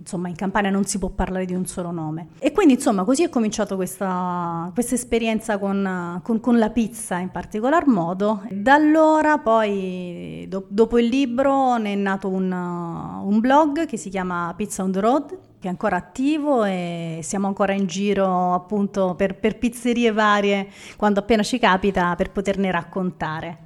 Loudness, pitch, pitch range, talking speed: -21 LUFS, 200 Hz, 185-230 Hz, 175 wpm